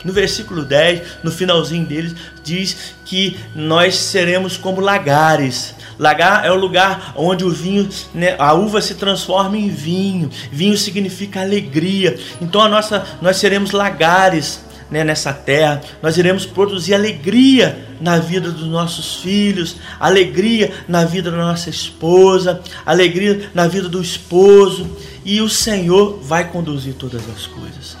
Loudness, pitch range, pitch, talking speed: -15 LUFS, 160-195 Hz, 180 Hz, 140 wpm